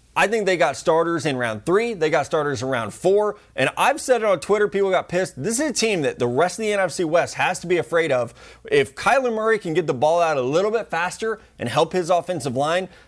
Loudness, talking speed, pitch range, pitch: -21 LUFS, 255 wpm, 160-215 Hz, 180 Hz